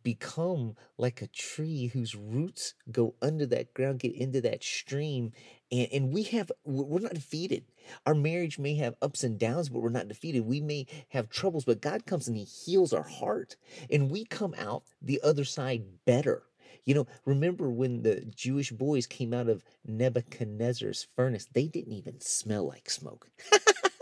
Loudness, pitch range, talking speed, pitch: -31 LUFS, 120-155 Hz, 175 wpm, 135 Hz